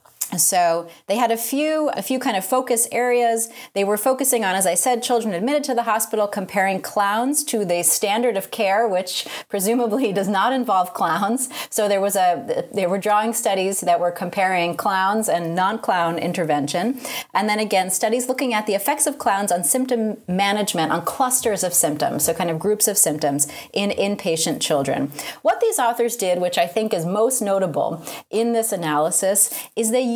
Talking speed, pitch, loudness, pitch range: 185 wpm, 205 Hz, -20 LUFS, 180-240 Hz